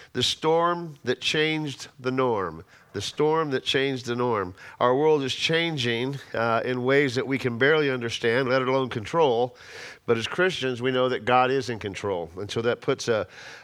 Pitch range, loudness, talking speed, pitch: 125-150 Hz, -25 LUFS, 185 wpm, 130 Hz